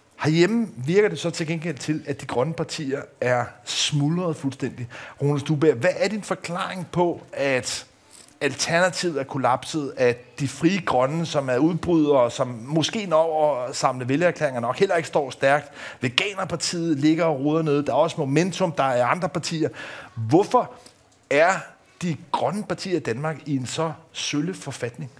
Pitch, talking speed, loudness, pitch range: 150 Hz, 160 wpm, -23 LUFS, 135-170 Hz